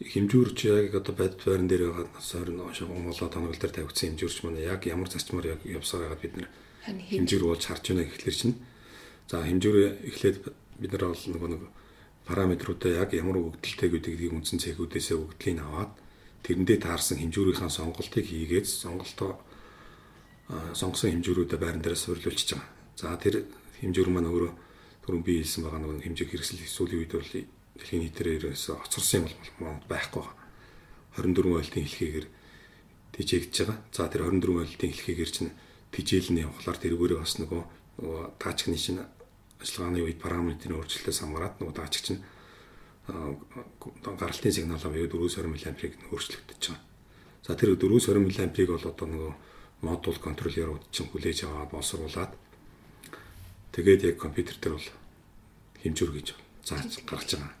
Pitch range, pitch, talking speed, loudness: 80-95 Hz, 85 Hz, 140 wpm, -30 LUFS